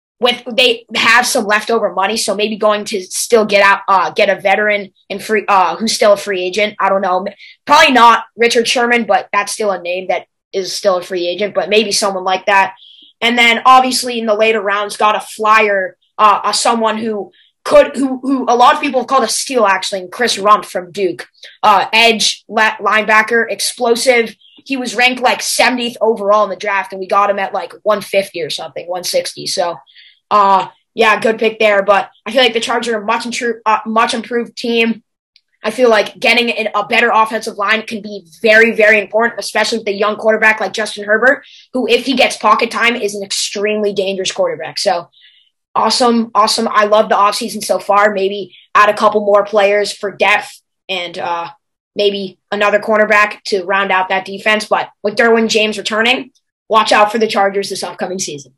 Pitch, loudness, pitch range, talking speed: 210 Hz, -13 LUFS, 200-230 Hz, 200 wpm